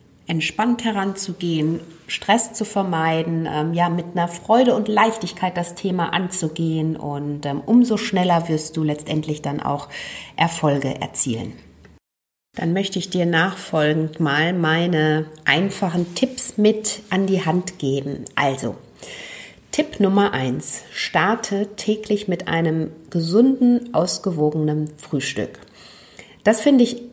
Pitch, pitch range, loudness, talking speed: 175 Hz, 155-205 Hz, -20 LUFS, 120 wpm